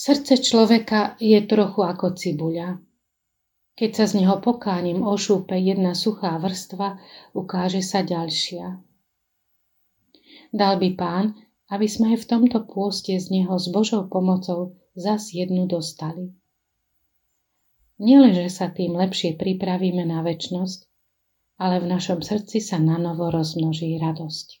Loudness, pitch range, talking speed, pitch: -22 LUFS, 175-210 Hz, 120 wpm, 185 Hz